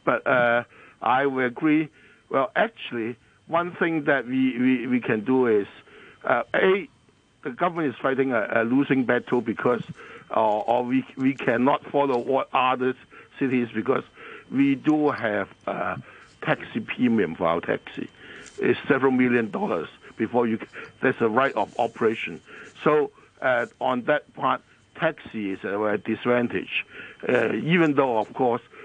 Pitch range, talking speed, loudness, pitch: 115-145 Hz, 150 wpm, -24 LUFS, 125 Hz